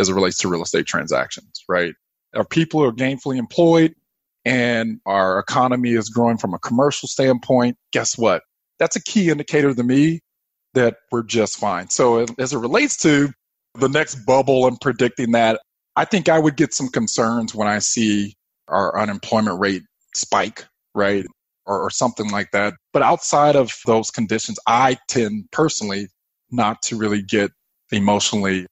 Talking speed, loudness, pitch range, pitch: 165 wpm, -19 LUFS, 105-145 Hz, 120 Hz